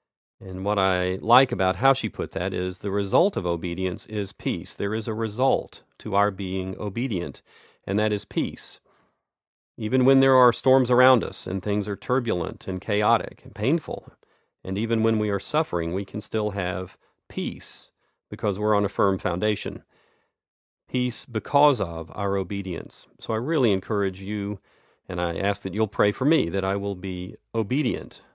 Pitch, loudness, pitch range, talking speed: 100 Hz, -25 LUFS, 95-115 Hz, 175 wpm